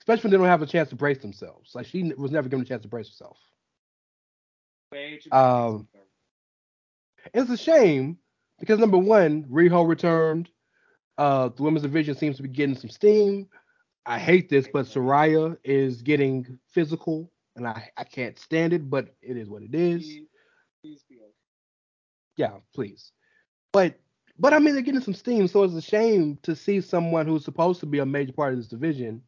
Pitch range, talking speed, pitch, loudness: 135-185 Hz, 175 wpm, 155 Hz, -23 LUFS